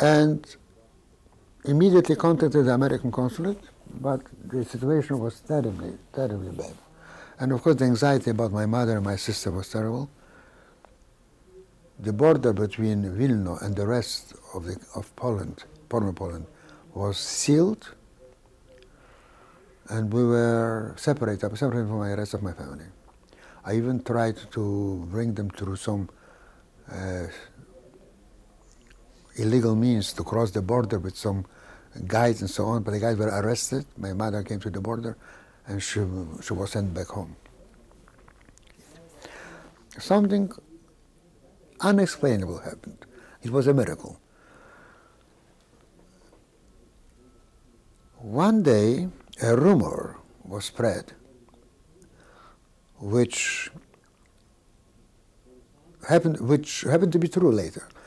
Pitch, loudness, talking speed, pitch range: 115 Hz, -25 LUFS, 115 wpm, 100-135 Hz